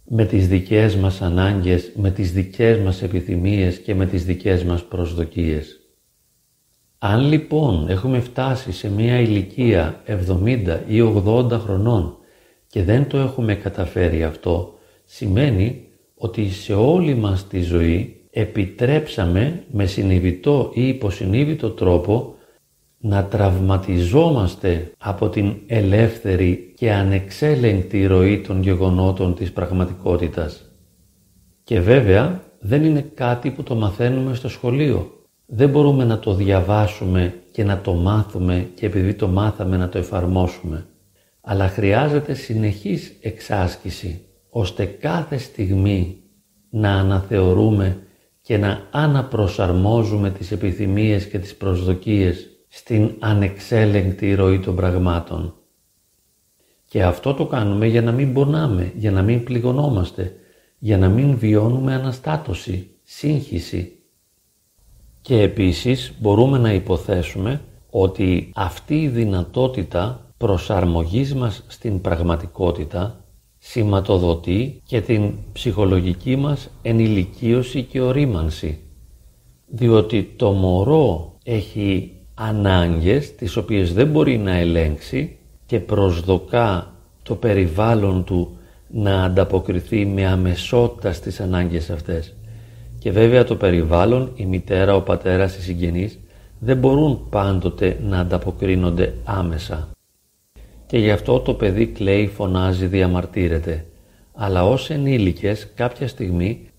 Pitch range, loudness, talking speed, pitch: 90-115 Hz, -19 LUFS, 110 wpm, 100 Hz